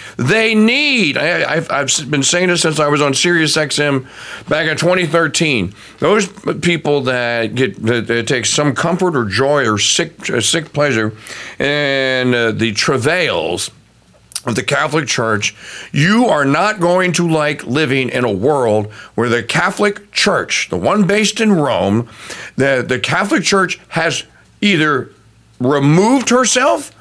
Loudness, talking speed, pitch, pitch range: -14 LUFS, 150 wpm, 150 Hz, 120-180 Hz